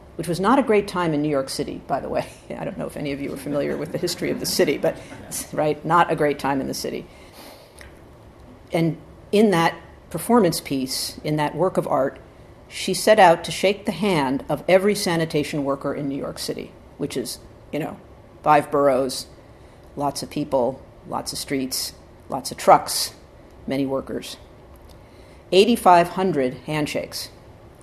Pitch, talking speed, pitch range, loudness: 150 Hz, 175 wpm, 140-180 Hz, -22 LUFS